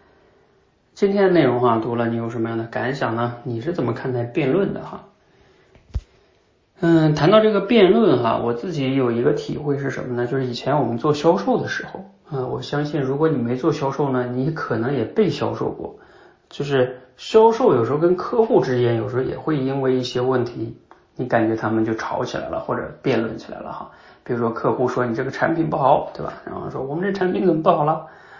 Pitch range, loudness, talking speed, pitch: 120-160 Hz, -20 LUFS, 315 characters per minute, 130 Hz